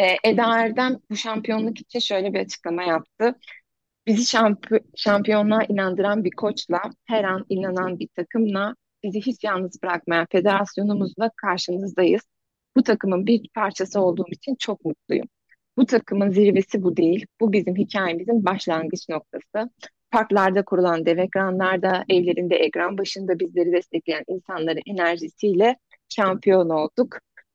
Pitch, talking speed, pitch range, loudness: 195 Hz, 125 wpm, 180-220 Hz, -22 LUFS